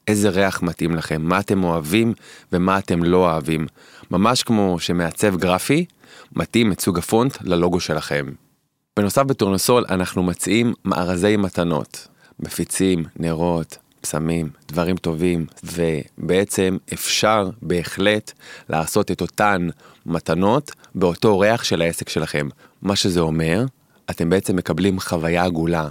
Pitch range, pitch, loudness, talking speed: 85-105 Hz, 90 Hz, -20 LUFS, 120 wpm